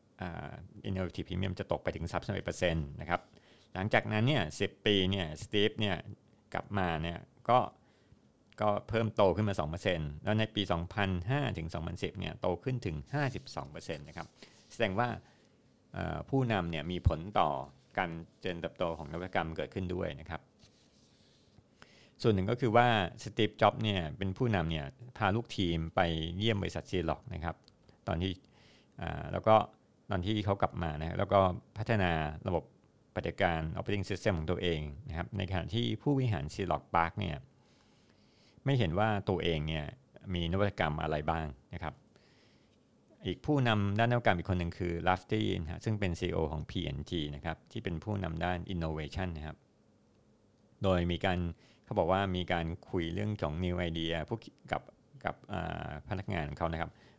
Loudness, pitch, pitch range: -34 LUFS, 95 Hz, 85-105 Hz